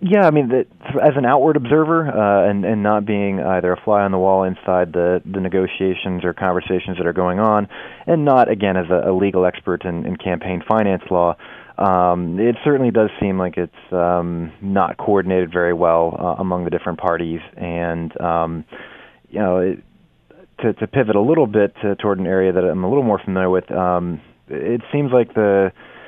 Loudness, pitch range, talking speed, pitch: -18 LUFS, 90-105 Hz, 200 wpm, 95 Hz